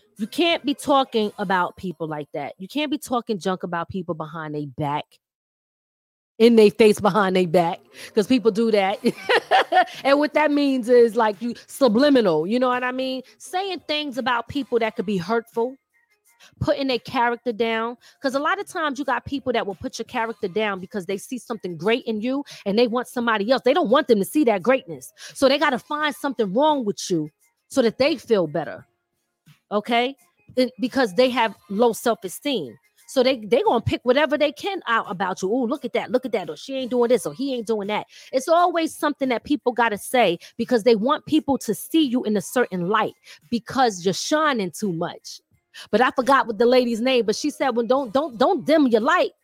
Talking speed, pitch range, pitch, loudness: 215 wpm, 210-270 Hz, 240 Hz, -22 LUFS